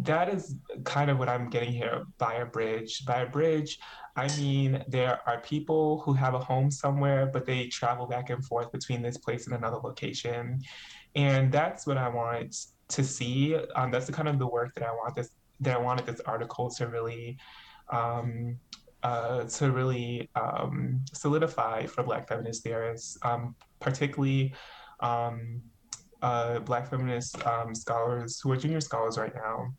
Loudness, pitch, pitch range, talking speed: -31 LUFS, 125 Hz, 120-140 Hz, 170 wpm